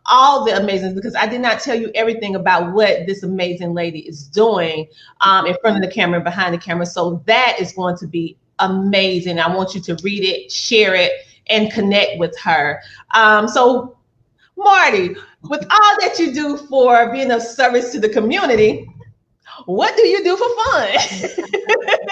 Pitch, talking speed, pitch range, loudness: 215 Hz, 180 wpm, 185-260 Hz, -15 LUFS